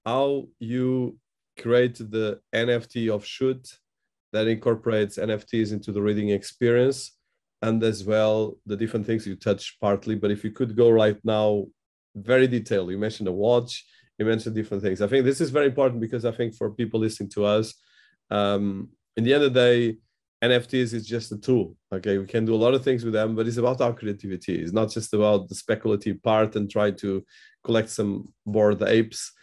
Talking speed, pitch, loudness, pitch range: 195 wpm, 110 Hz, -24 LUFS, 105-120 Hz